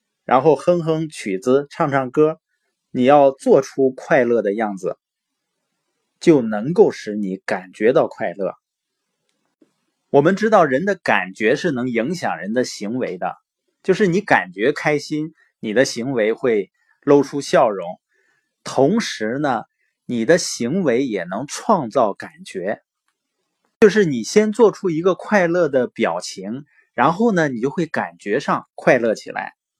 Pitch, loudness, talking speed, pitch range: 155 Hz, -19 LUFS, 200 characters per minute, 130-185 Hz